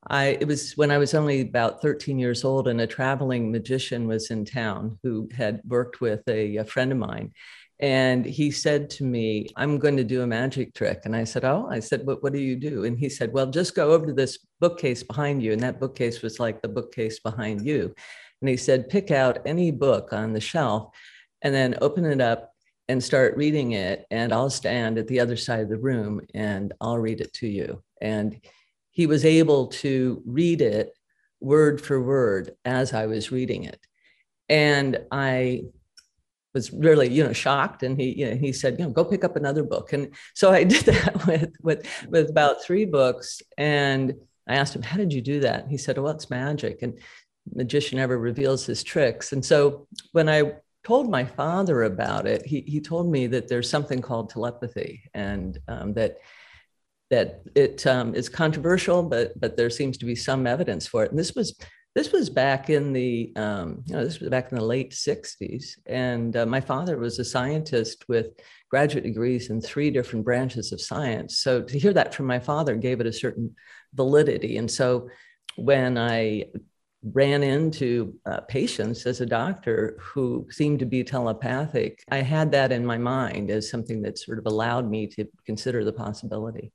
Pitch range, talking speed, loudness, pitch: 115-145 Hz, 200 wpm, -24 LUFS, 130 Hz